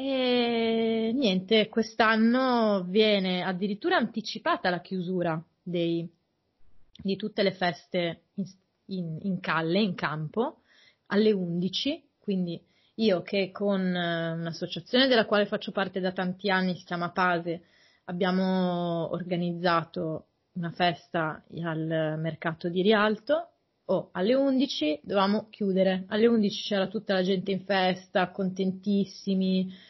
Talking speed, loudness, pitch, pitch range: 120 wpm, -27 LUFS, 190 Hz, 175-215 Hz